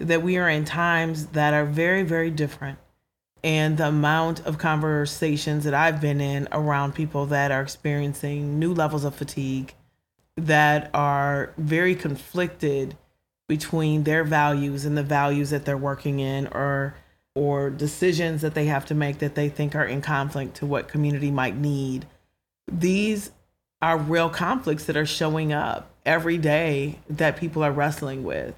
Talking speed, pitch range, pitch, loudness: 160 wpm, 140-160 Hz, 150 Hz, -24 LUFS